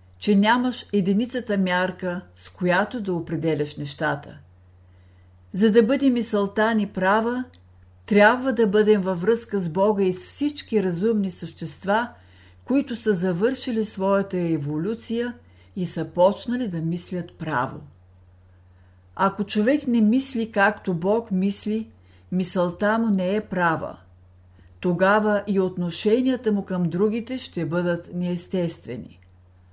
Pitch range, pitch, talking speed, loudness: 155-215 Hz, 185 Hz, 120 wpm, -23 LUFS